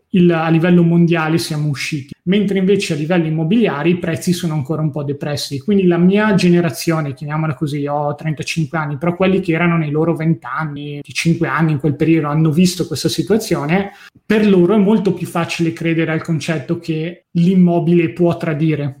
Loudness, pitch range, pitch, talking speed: -16 LUFS, 155-175 Hz, 165 Hz, 185 wpm